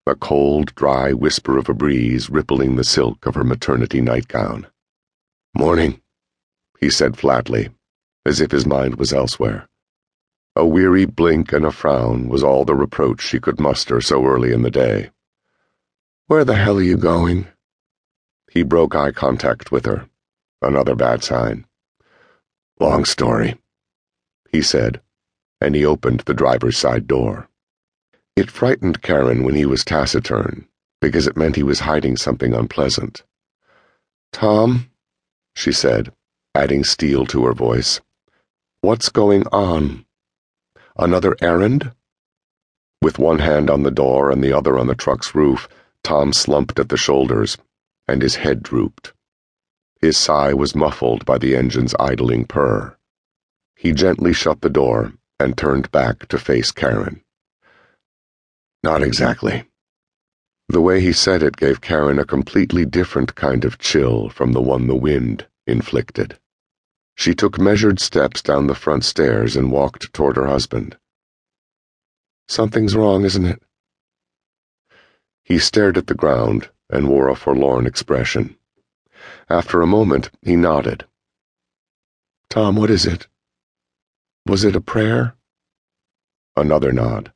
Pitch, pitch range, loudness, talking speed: 70 Hz, 65-90 Hz, -17 LUFS, 140 wpm